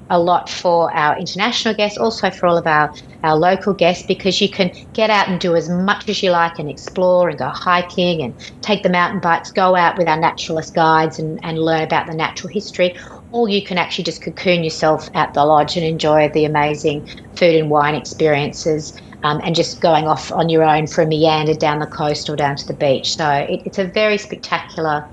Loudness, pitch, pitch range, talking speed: -17 LUFS, 165 Hz, 155-180 Hz, 220 wpm